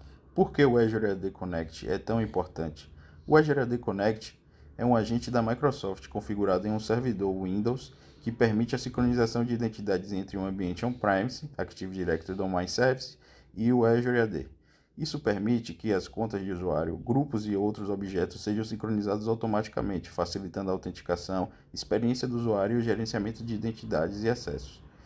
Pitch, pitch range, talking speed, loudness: 105 Hz, 95-120 Hz, 160 wpm, -30 LUFS